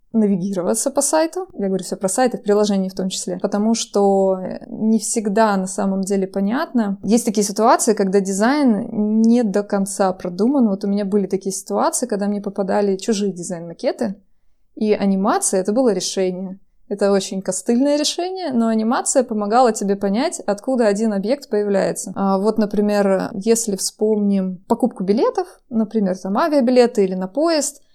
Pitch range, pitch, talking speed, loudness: 195-235 Hz, 210 Hz, 155 wpm, -19 LUFS